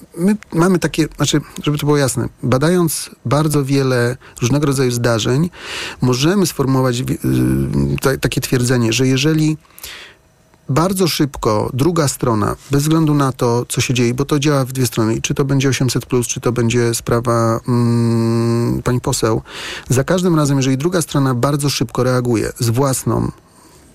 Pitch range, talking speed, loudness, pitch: 120-150 Hz, 150 wpm, -16 LUFS, 135 Hz